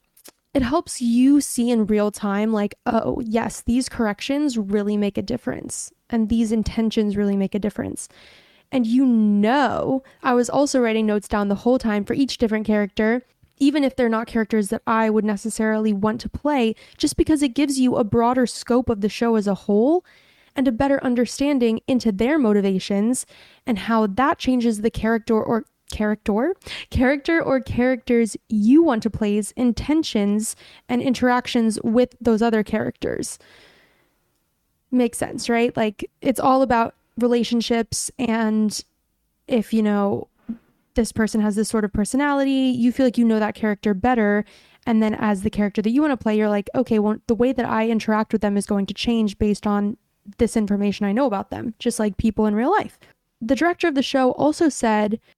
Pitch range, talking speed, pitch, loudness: 215-255 Hz, 180 wpm, 230 Hz, -21 LUFS